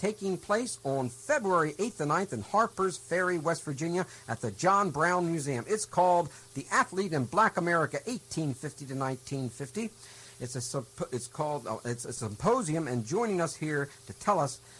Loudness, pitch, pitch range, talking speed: -31 LUFS, 150 Hz, 130-185 Hz, 175 wpm